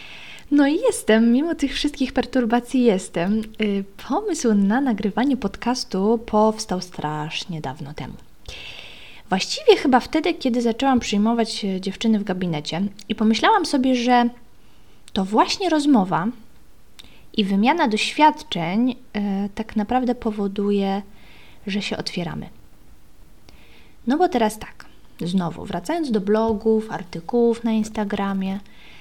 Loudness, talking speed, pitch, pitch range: -21 LUFS, 110 wpm, 220 Hz, 195-250 Hz